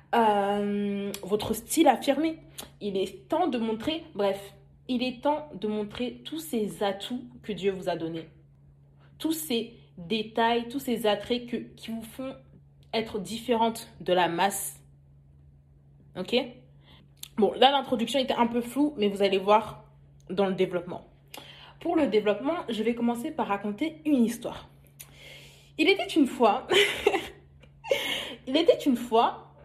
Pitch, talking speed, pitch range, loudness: 220 Hz, 145 wpm, 185-265 Hz, -27 LUFS